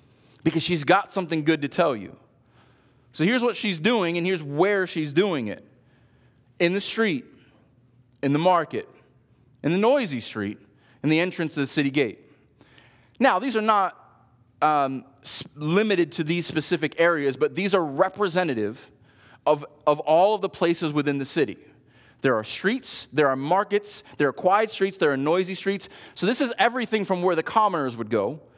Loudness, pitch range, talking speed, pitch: -24 LUFS, 135-185 Hz, 175 wpm, 150 Hz